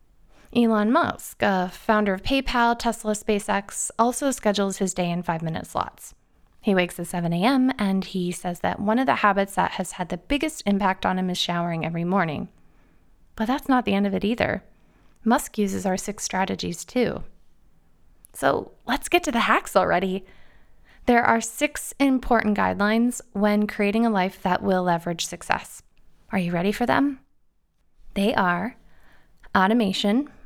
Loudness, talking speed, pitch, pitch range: -23 LUFS, 160 wpm, 205 Hz, 185-230 Hz